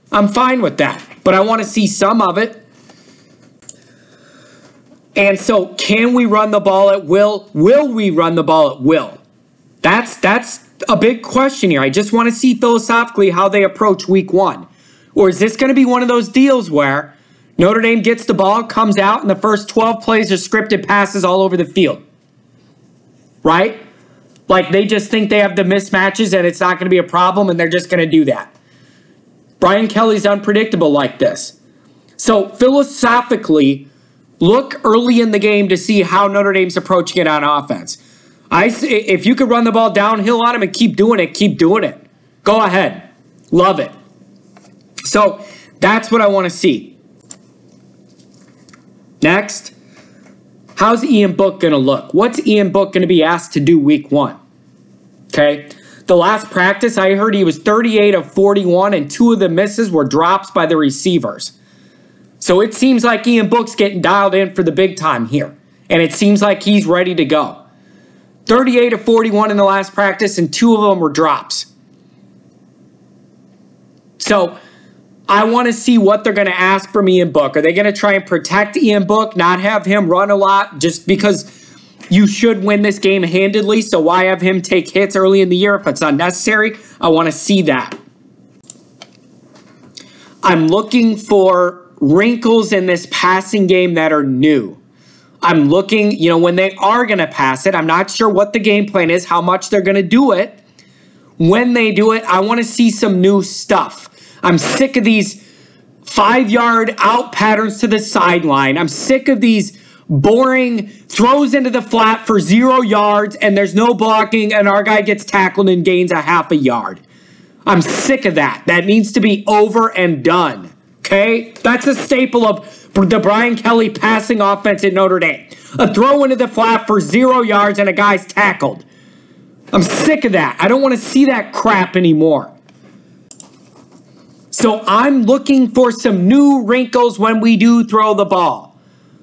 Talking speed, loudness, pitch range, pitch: 180 wpm, -12 LUFS, 180-225 Hz, 200 Hz